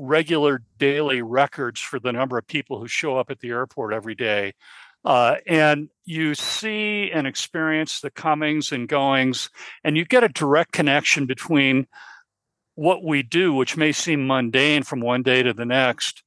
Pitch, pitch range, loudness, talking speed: 140 Hz, 130-155 Hz, -21 LUFS, 170 wpm